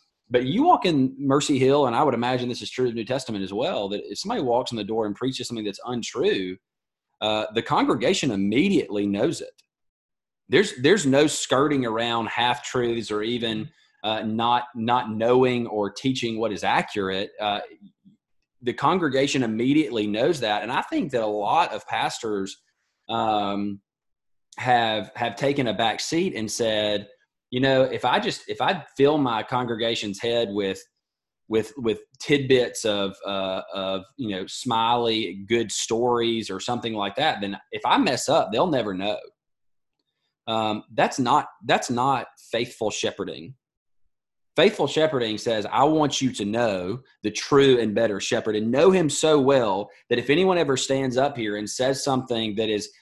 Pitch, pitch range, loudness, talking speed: 115 Hz, 105-130 Hz, -23 LUFS, 170 wpm